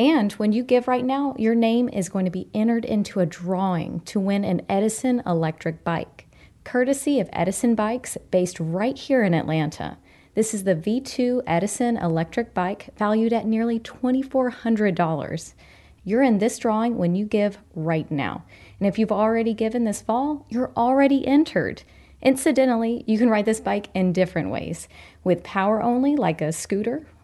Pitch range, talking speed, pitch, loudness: 185-245 Hz, 165 wpm, 220 Hz, -23 LUFS